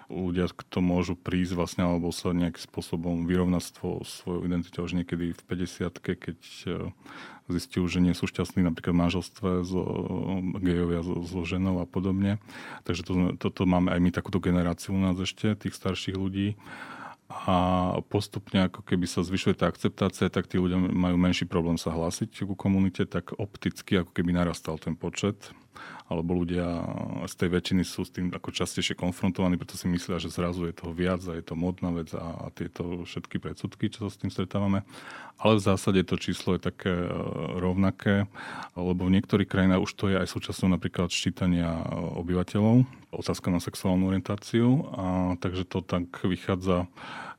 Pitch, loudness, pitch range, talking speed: 90 Hz, -28 LUFS, 90-95 Hz, 175 wpm